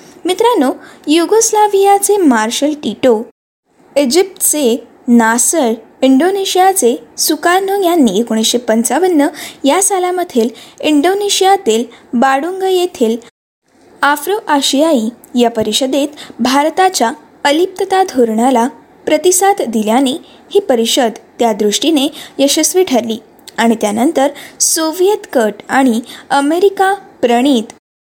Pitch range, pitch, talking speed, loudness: 235-365 Hz, 285 Hz, 80 wpm, -12 LUFS